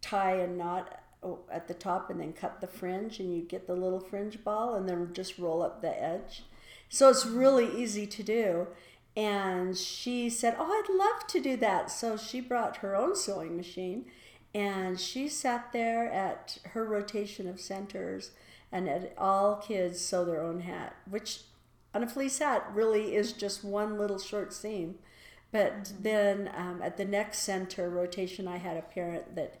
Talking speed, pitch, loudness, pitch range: 180 wpm, 200 Hz, -32 LUFS, 180-220 Hz